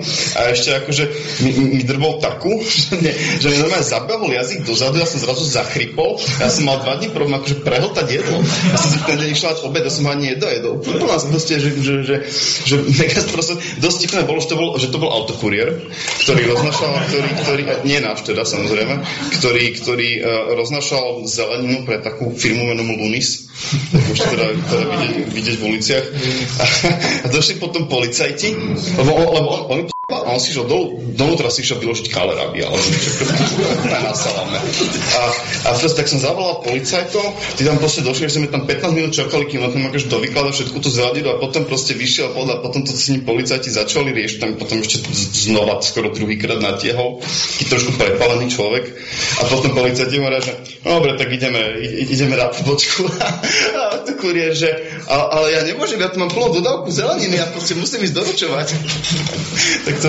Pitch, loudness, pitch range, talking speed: 140 Hz, -16 LUFS, 125-160 Hz, 185 wpm